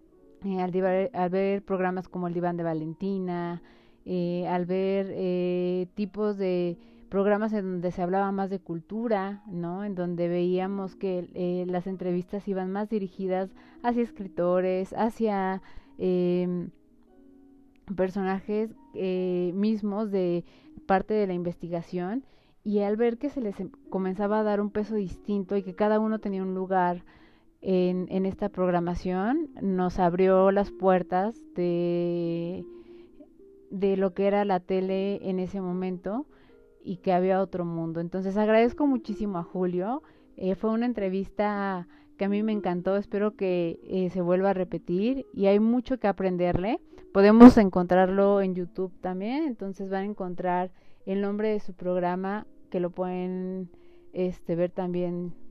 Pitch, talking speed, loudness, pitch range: 190 Hz, 150 wpm, -27 LUFS, 180-210 Hz